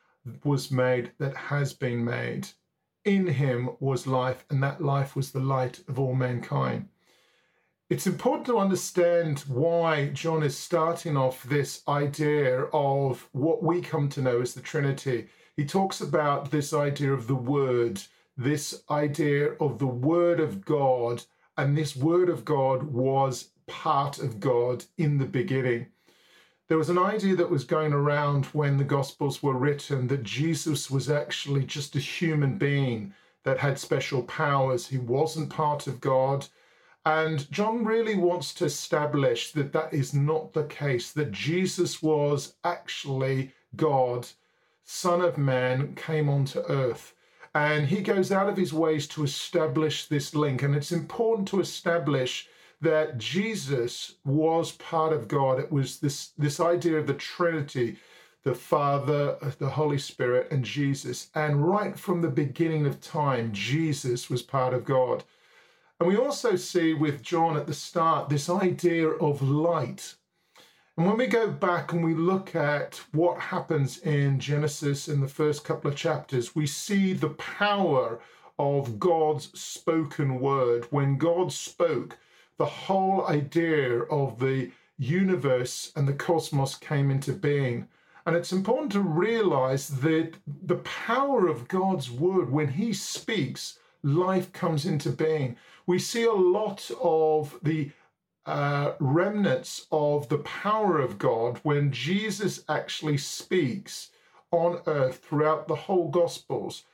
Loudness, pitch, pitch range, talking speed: -27 LUFS, 150 Hz, 140-170 Hz, 150 wpm